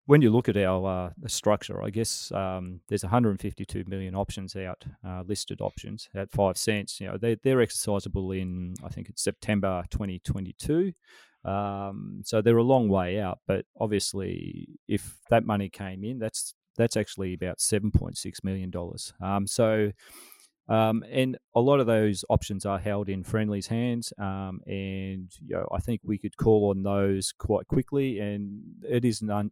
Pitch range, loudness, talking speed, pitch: 95-115 Hz, -28 LUFS, 170 wpm, 105 Hz